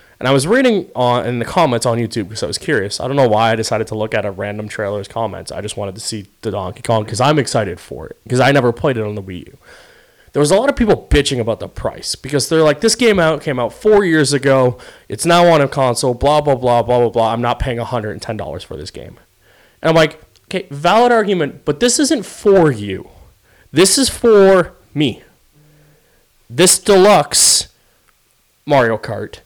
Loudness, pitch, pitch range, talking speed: -14 LUFS, 130 Hz, 115-160 Hz, 220 wpm